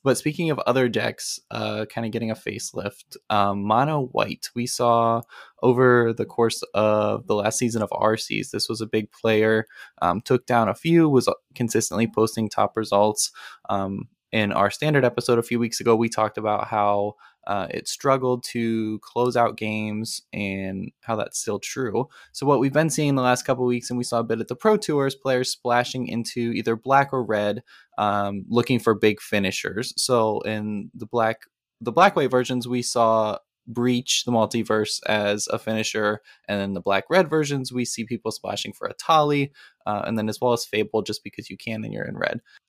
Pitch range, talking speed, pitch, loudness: 105-125 Hz, 195 wpm, 115 Hz, -23 LUFS